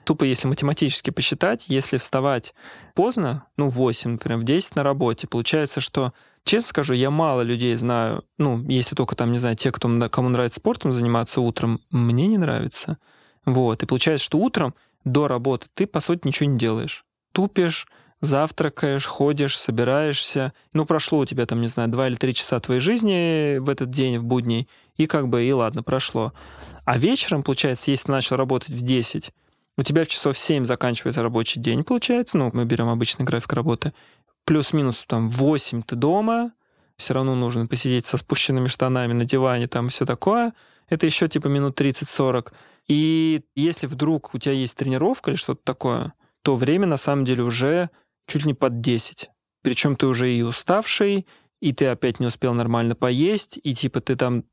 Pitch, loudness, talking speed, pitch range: 135 Hz, -22 LUFS, 180 wpm, 120-150 Hz